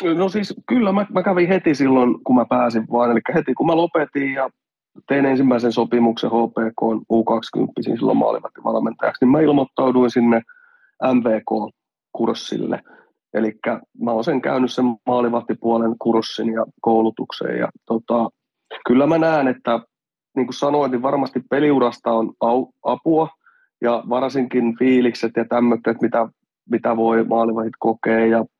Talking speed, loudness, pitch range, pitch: 140 wpm, -19 LUFS, 115-140 Hz, 120 Hz